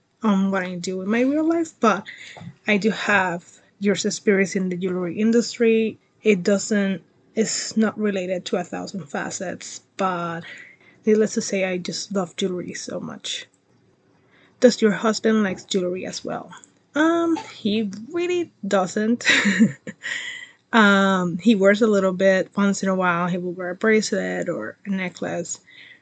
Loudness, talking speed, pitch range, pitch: -22 LUFS, 150 wpm, 185-225 Hz, 205 Hz